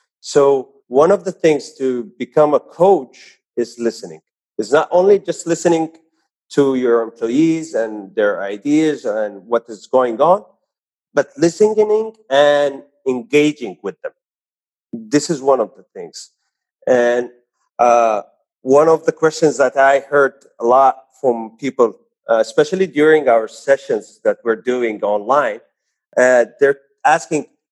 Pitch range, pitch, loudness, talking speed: 120-165 Hz, 145 Hz, -16 LUFS, 140 wpm